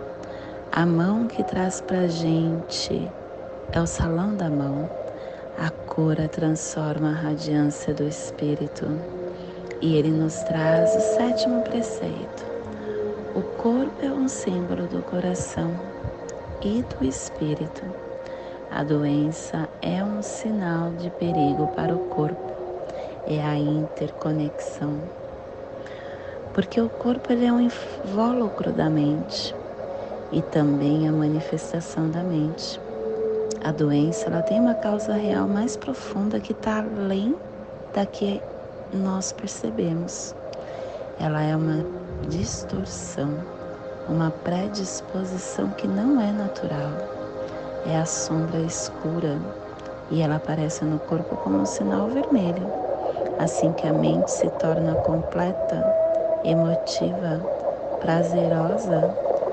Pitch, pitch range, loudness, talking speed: 165 Hz, 150-210 Hz, -25 LUFS, 115 wpm